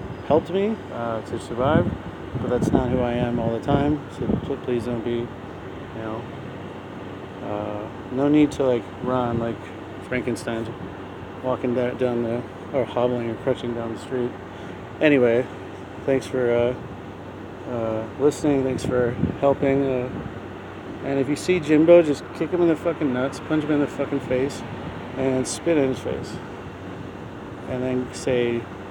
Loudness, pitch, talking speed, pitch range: -23 LUFS, 120 Hz, 155 wpm, 100-130 Hz